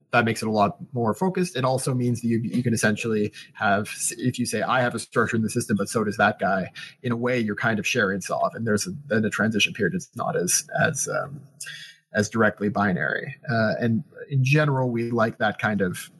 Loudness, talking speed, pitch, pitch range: -24 LUFS, 235 wpm, 115 Hz, 105-125 Hz